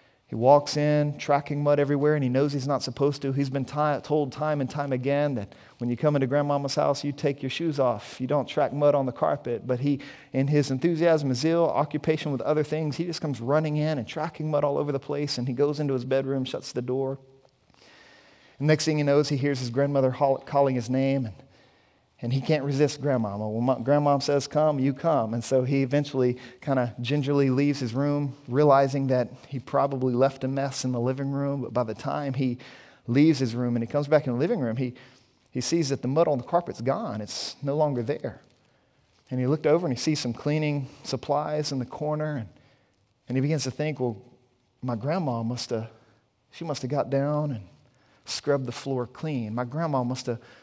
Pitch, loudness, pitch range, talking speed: 140 Hz, -26 LUFS, 125-145 Hz, 220 wpm